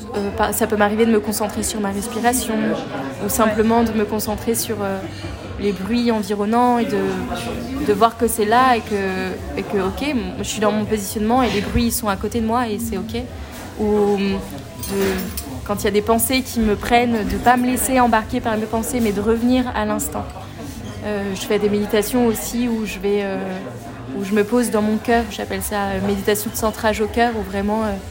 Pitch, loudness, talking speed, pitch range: 215 Hz, -20 LUFS, 215 wpm, 205-230 Hz